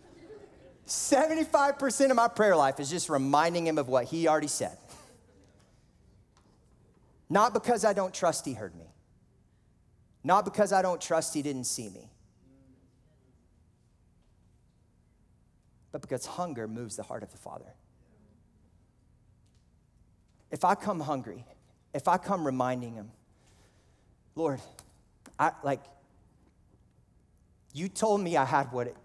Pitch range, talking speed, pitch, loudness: 115-190 Hz, 120 wpm, 145 Hz, -29 LUFS